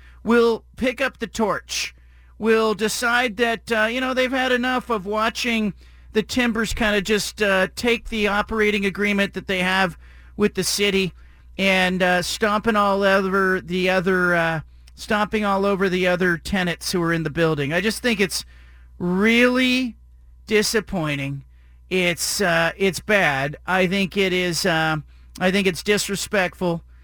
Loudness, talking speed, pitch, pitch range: -21 LUFS, 155 wpm, 195 Hz, 175-220 Hz